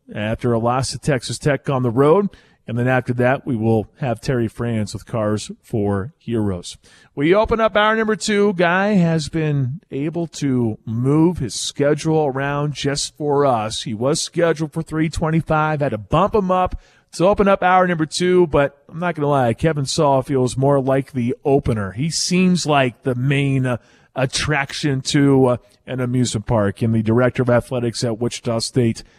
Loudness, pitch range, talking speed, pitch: -19 LUFS, 120-160 Hz, 185 wpm, 140 Hz